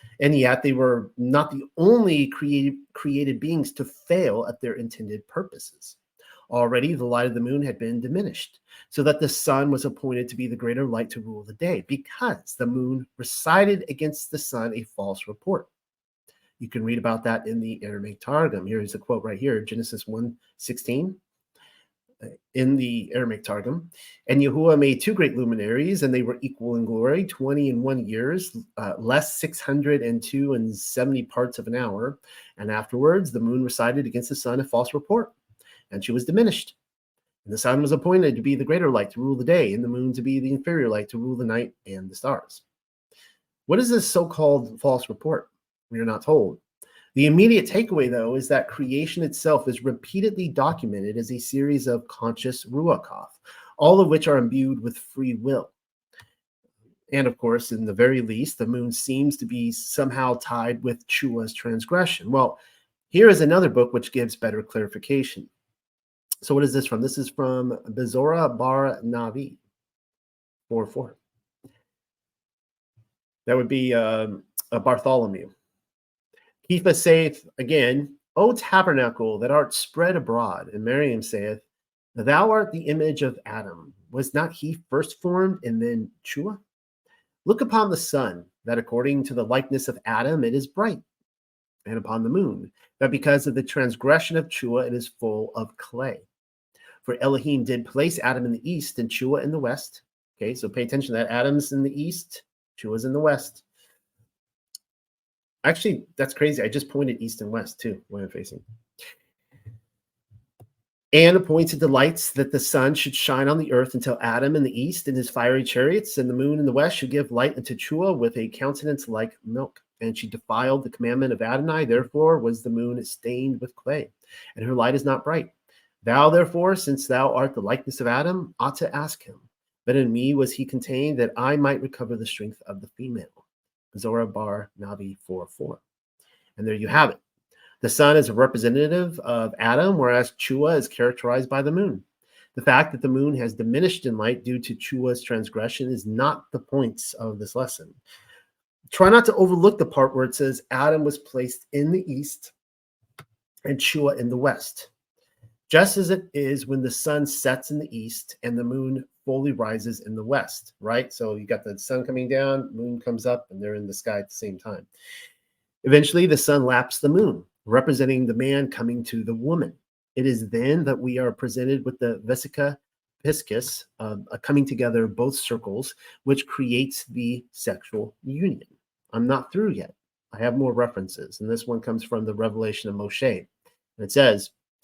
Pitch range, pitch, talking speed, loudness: 120-145 Hz, 130 Hz, 180 wpm, -23 LUFS